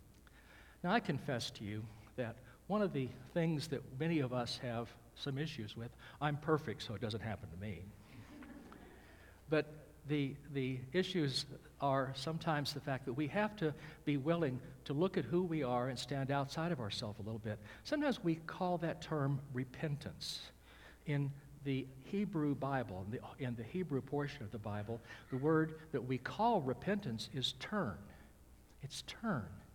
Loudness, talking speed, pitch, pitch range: -40 LUFS, 165 wpm, 135 Hz, 120-155 Hz